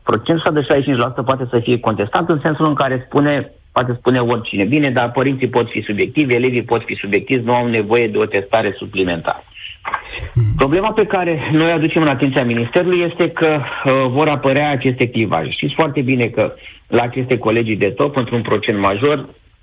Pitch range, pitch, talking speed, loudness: 115-145 Hz, 130 Hz, 180 wpm, -16 LUFS